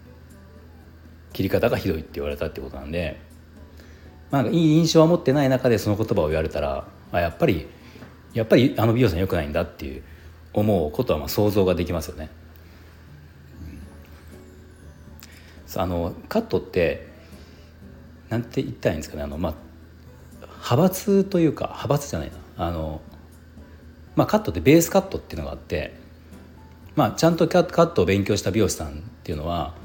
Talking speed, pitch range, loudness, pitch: 360 characters per minute, 80-105 Hz, -23 LUFS, 85 Hz